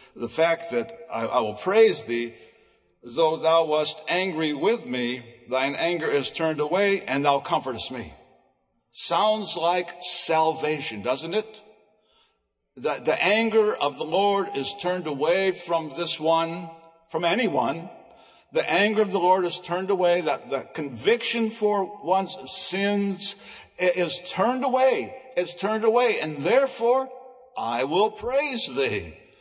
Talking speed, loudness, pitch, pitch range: 140 wpm, -24 LUFS, 180 Hz, 160-215 Hz